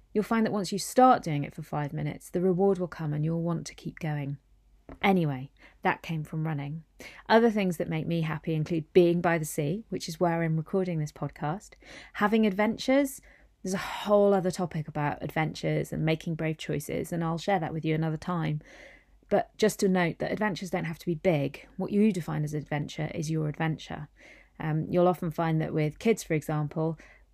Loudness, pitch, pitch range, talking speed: -29 LUFS, 165 Hz, 155-190 Hz, 205 wpm